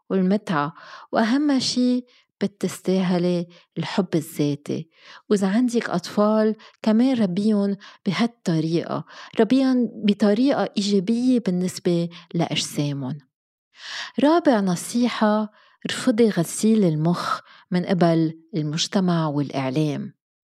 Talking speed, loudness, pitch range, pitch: 75 wpm, -22 LUFS, 170-230 Hz, 200 Hz